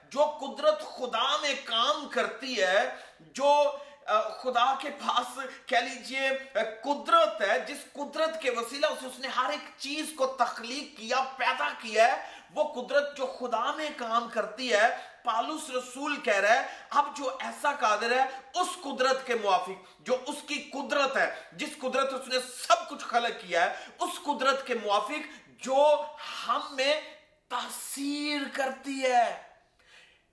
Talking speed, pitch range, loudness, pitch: 150 wpm, 245-295 Hz, -29 LUFS, 270 Hz